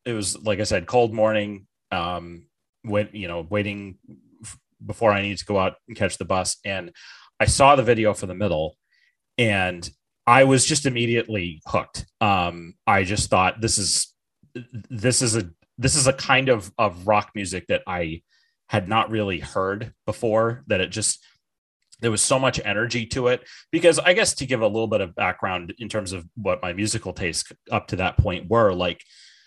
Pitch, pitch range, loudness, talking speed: 105 Hz, 95-115 Hz, -22 LUFS, 190 wpm